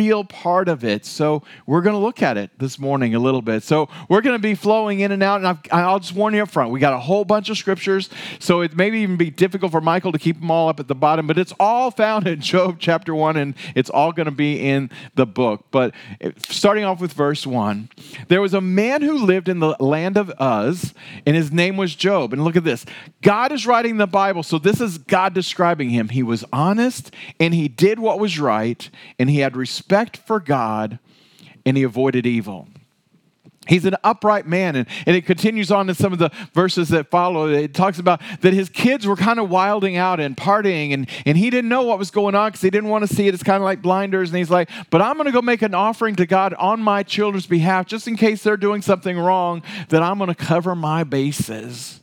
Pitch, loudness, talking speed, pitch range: 180 Hz, -18 LUFS, 240 wpm, 150-200 Hz